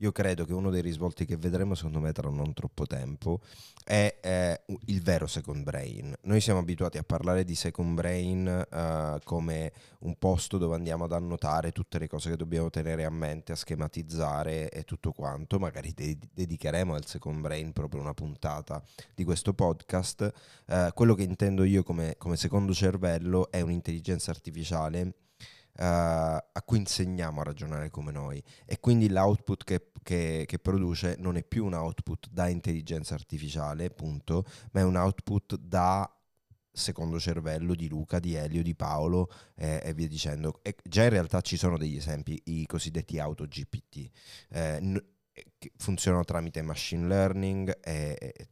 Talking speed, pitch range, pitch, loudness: 165 wpm, 80-95 Hz, 85 Hz, -31 LUFS